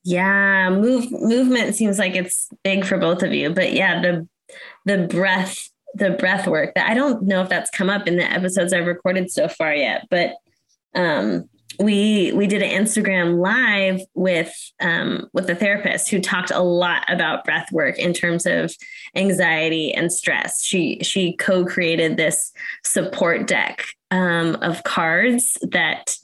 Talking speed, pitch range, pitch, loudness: 160 wpm, 180-205 Hz, 190 Hz, -19 LUFS